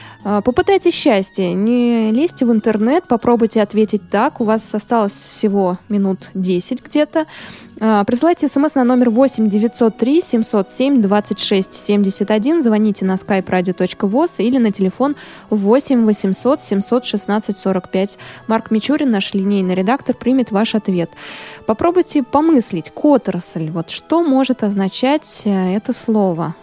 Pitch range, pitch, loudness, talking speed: 195-255 Hz, 220 Hz, -16 LUFS, 105 wpm